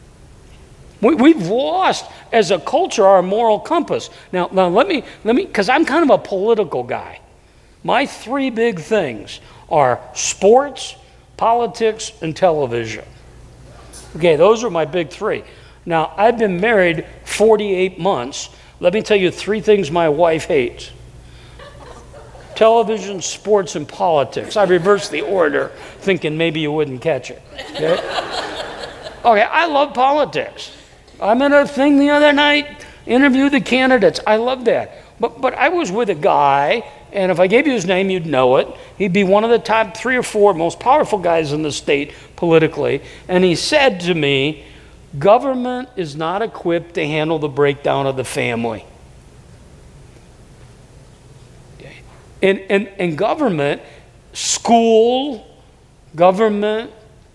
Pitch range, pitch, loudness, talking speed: 160-235 Hz, 195 Hz, -16 LUFS, 145 wpm